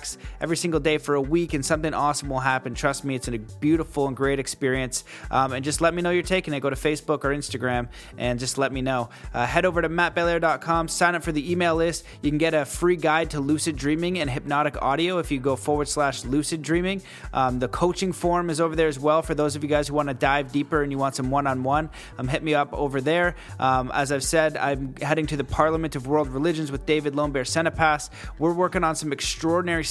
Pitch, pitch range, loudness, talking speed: 150 Hz, 135-165 Hz, -24 LUFS, 240 wpm